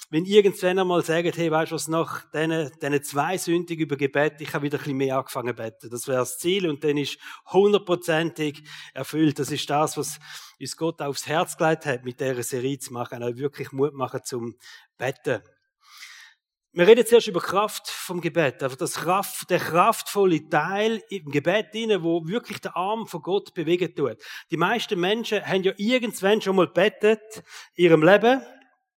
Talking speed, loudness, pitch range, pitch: 185 wpm, -24 LUFS, 145-195 Hz, 165 Hz